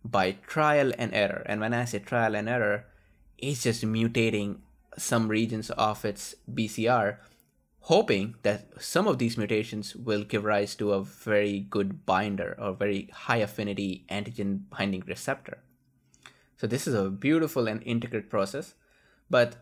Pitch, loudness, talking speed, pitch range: 110 Hz, -28 LUFS, 150 wpm, 100-120 Hz